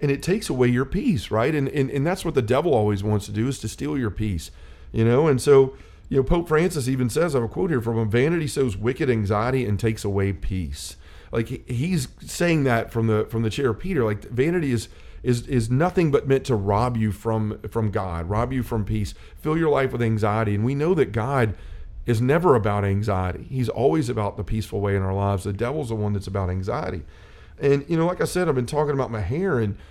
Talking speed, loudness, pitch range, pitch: 240 wpm, -23 LUFS, 105-135 Hz, 115 Hz